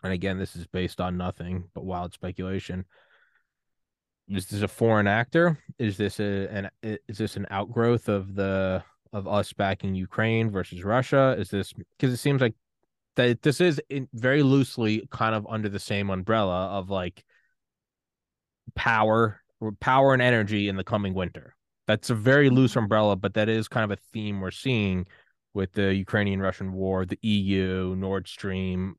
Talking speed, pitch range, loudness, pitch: 170 wpm, 95-115 Hz, -26 LUFS, 100 Hz